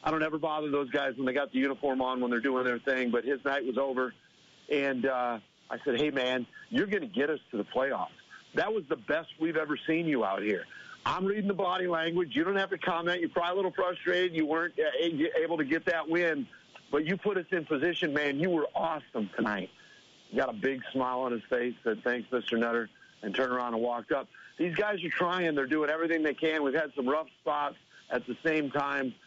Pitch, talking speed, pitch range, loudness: 150 Hz, 235 wpm, 130-170 Hz, -31 LUFS